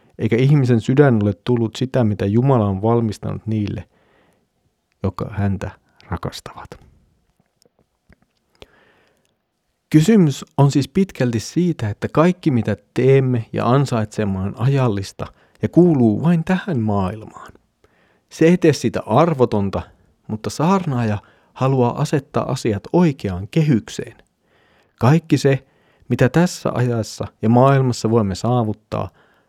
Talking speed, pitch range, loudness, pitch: 110 wpm, 105-140 Hz, -18 LUFS, 120 Hz